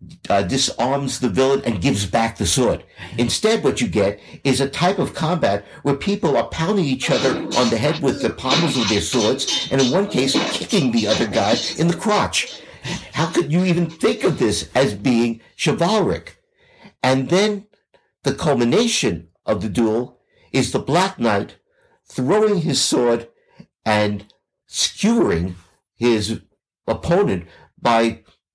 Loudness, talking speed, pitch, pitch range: -19 LUFS, 155 wpm, 135 Hz, 115-180 Hz